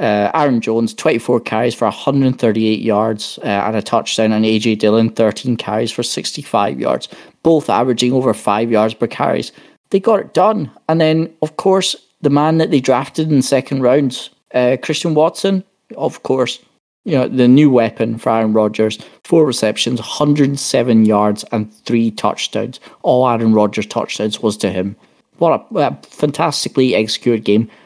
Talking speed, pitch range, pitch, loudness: 165 wpm, 110-145 Hz, 120 Hz, -15 LUFS